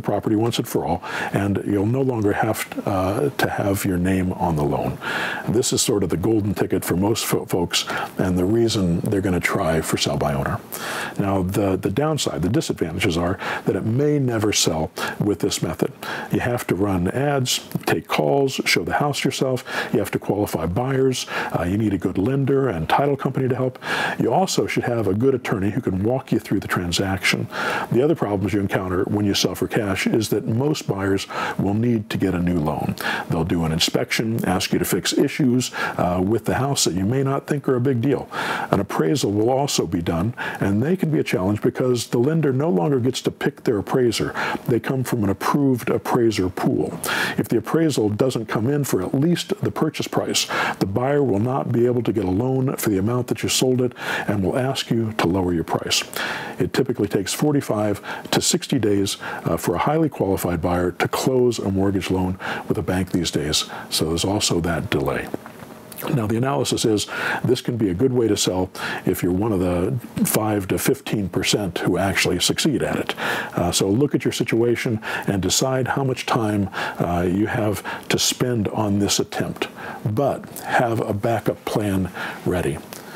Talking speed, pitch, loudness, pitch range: 205 wpm, 110 Hz, -21 LUFS, 95-130 Hz